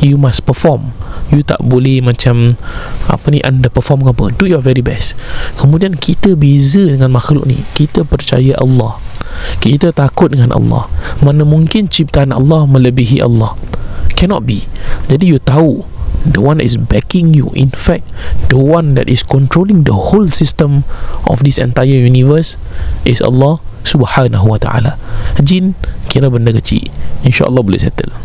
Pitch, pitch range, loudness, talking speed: 135 Hz, 125-150 Hz, -10 LUFS, 150 wpm